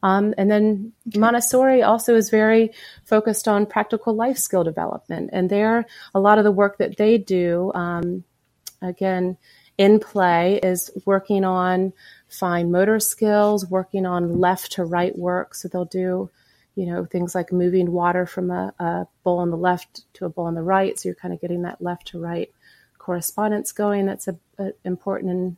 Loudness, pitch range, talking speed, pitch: -21 LUFS, 180-210 Hz, 180 wpm, 185 Hz